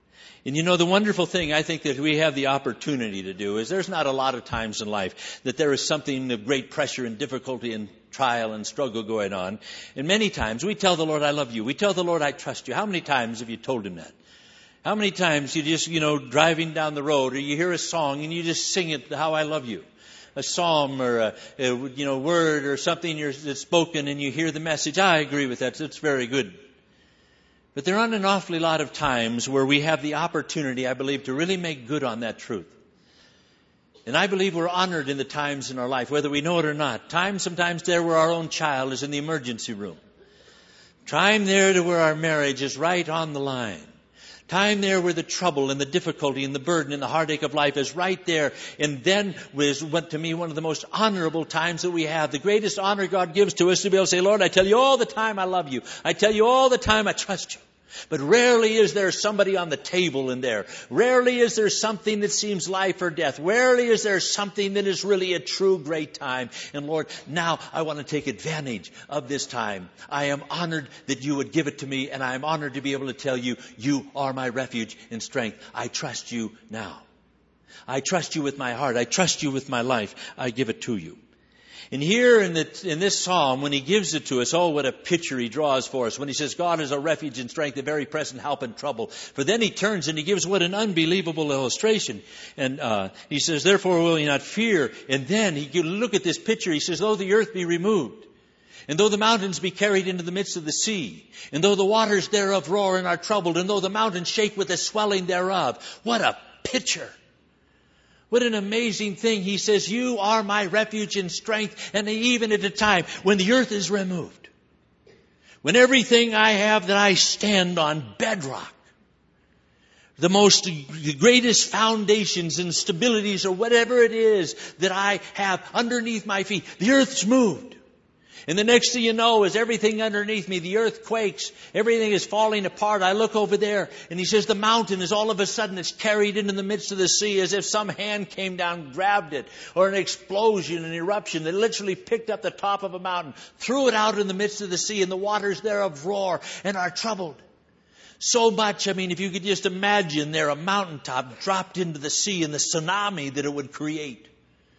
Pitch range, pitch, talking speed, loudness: 145-205 Hz, 175 Hz, 225 wpm, -23 LUFS